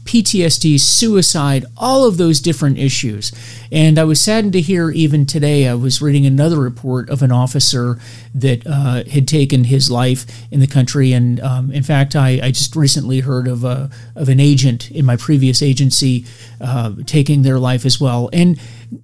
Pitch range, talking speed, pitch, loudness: 125-150 Hz, 180 wpm, 135 Hz, -14 LUFS